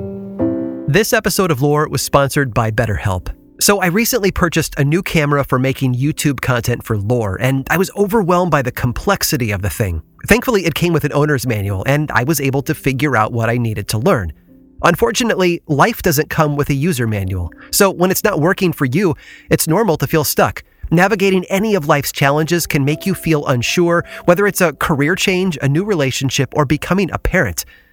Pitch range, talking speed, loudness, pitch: 125-180 Hz, 200 wpm, -15 LUFS, 150 Hz